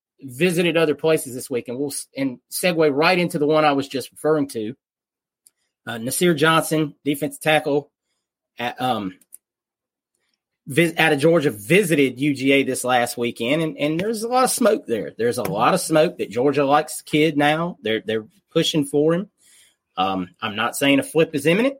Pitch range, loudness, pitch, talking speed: 130-165 Hz, -20 LUFS, 150 Hz, 180 wpm